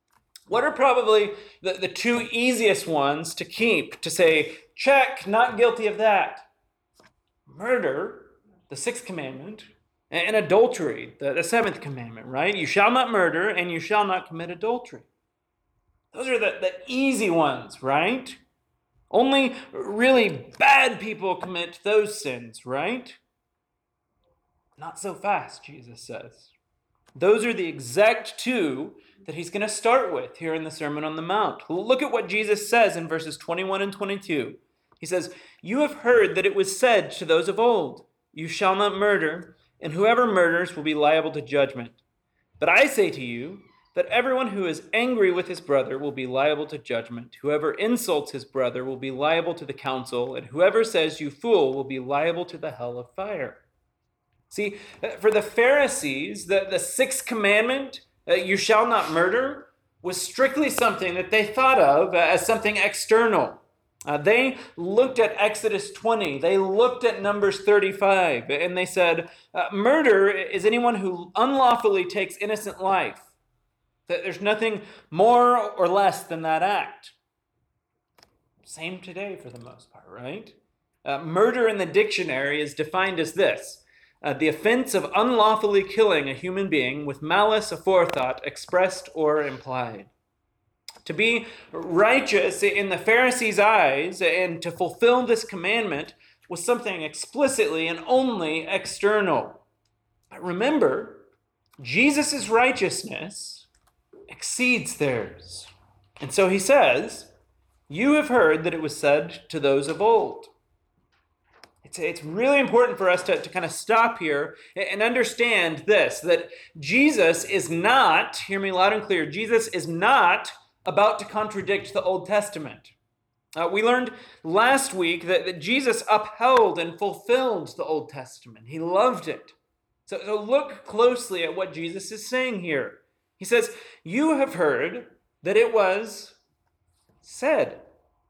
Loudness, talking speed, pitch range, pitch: -23 LUFS, 150 wpm, 165-240 Hz, 205 Hz